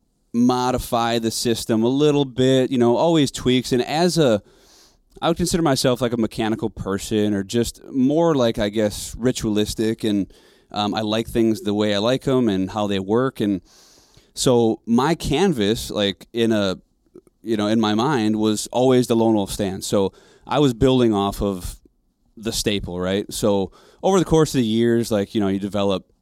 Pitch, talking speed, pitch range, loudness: 115 Hz, 185 wpm, 105-125 Hz, -20 LUFS